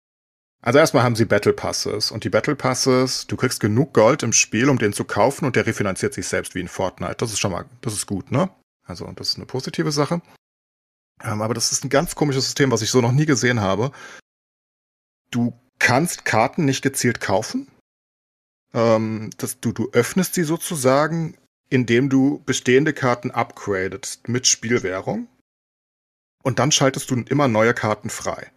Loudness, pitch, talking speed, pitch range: -20 LUFS, 130 Hz, 170 wpm, 115-145 Hz